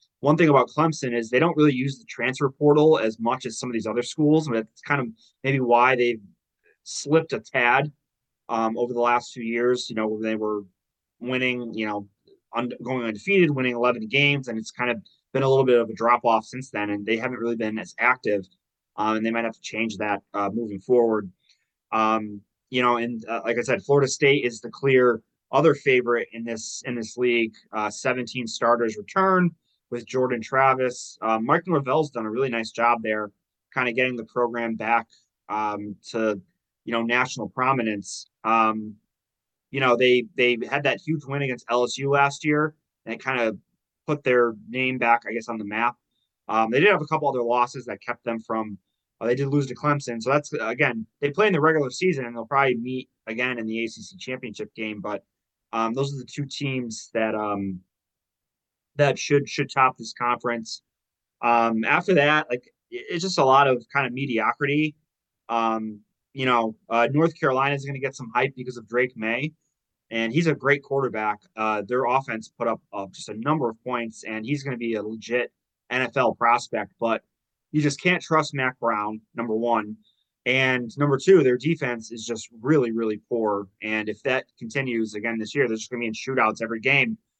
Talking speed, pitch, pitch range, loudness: 205 wpm, 120 Hz, 110-135 Hz, -24 LUFS